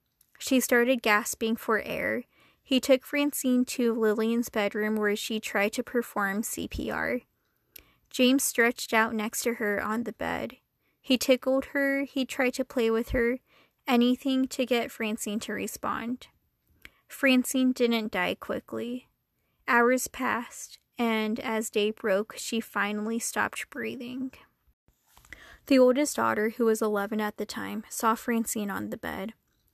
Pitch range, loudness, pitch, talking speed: 220-255 Hz, -28 LUFS, 235 Hz, 140 wpm